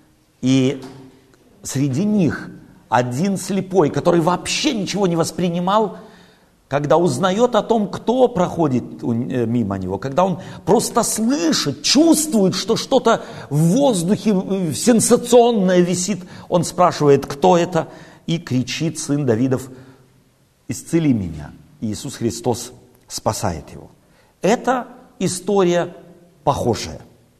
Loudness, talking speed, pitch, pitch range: -18 LUFS, 100 wpm, 175 Hz, 135-205 Hz